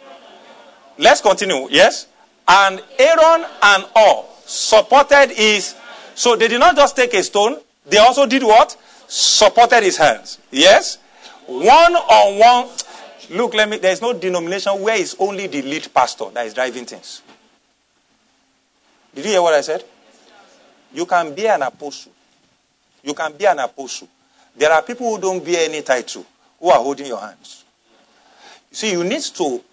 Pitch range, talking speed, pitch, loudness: 185-275 Hz, 155 wpm, 215 Hz, -14 LUFS